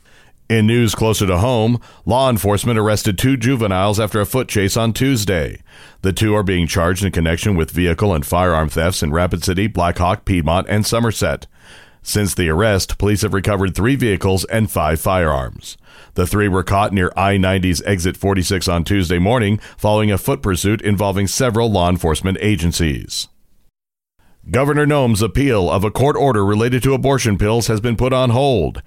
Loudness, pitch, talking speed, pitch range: -16 LUFS, 100 Hz, 175 wpm, 90-115 Hz